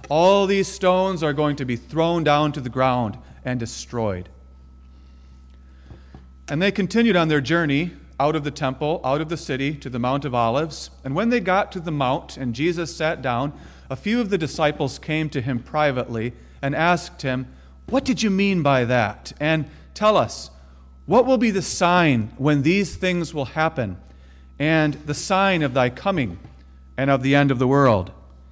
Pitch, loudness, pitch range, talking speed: 145 Hz, -21 LUFS, 120-170 Hz, 185 wpm